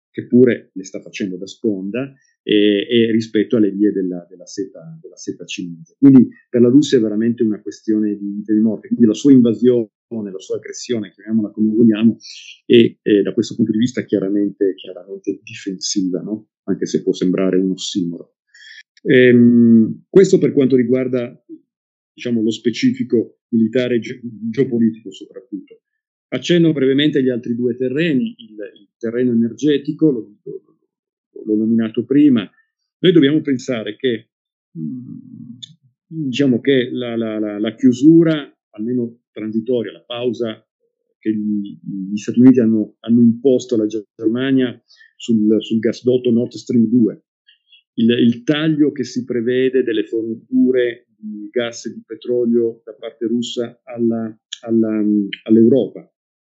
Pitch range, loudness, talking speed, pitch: 110-135 Hz, -16 LUFS, 140 wpm, 120 Hz